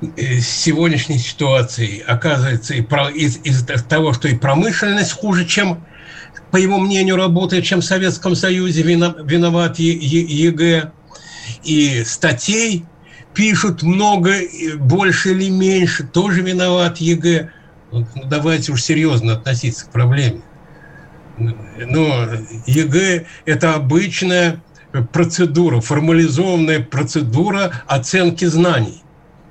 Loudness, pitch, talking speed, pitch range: -15 LUFS, 160 Hz, 95 wpm, 140-175 Hz